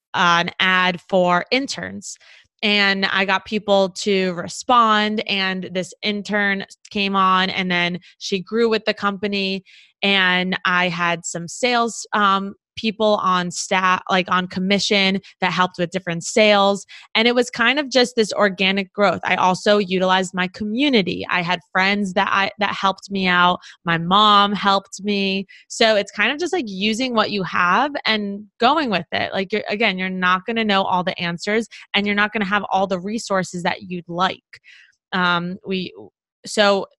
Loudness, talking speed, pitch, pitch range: -19 LUFS, 175 wpm, 195 Hz, 185-210 Hz